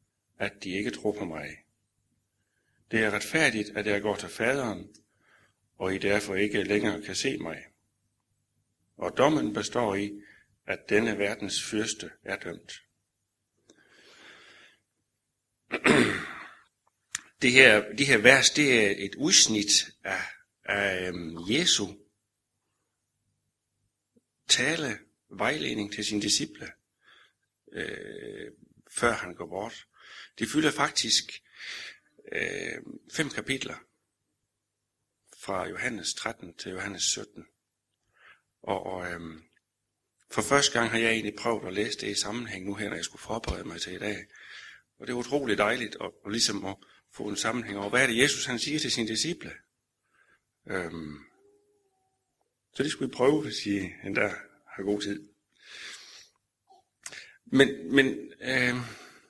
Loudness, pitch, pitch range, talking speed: -27 LUFS, 105 Hz, 100-120 Hz, 130 wpm